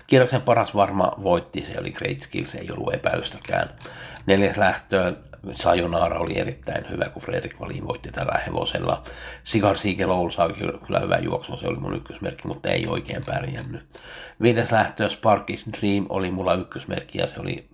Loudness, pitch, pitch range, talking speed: -24 LUFS, 100 Hz, 95-115 Hz, 160 wpm